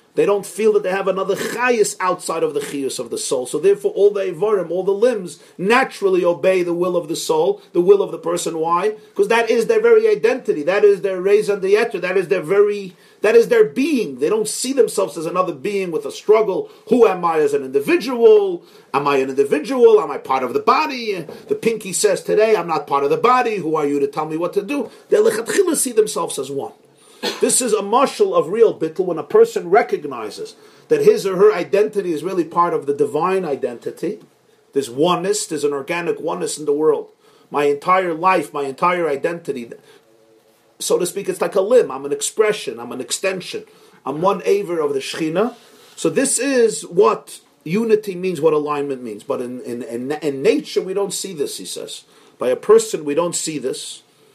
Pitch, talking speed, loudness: 240 Hz, 210 wpm, -18 LUFS